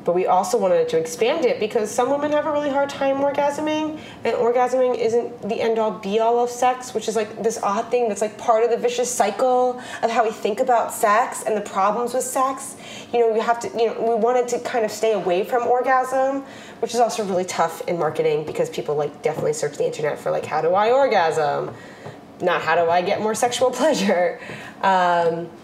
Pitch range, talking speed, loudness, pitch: 220-265 Hz, 220 wpm, -21 LUFS, 240 Hz